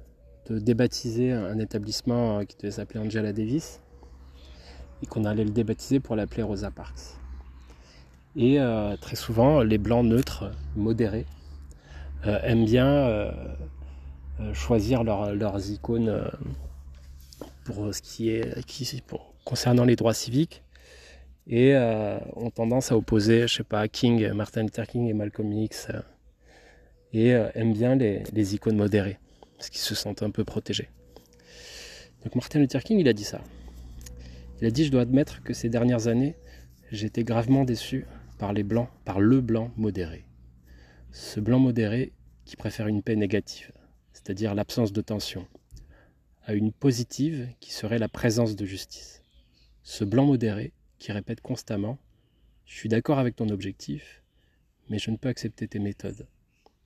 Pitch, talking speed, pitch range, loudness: 110 Hz, 150 wpm, 75-120 Hz, -26 LUFS